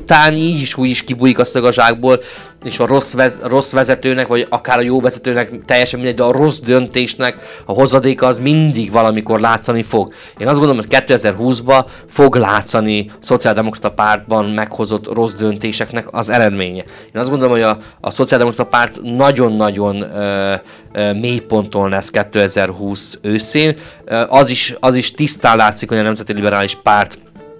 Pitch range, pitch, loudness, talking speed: 110-130 Hz, 120 Hz, -13 LUFS, 155 wpm